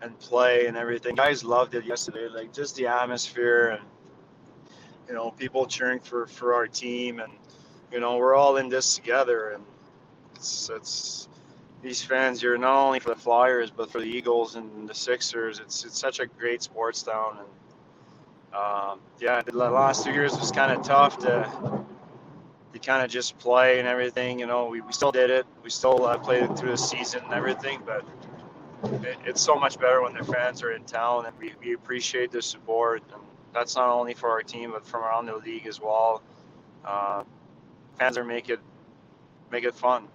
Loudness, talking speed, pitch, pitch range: -26 LUFS, 190 wpm, 120 Hz, 115-130 Hz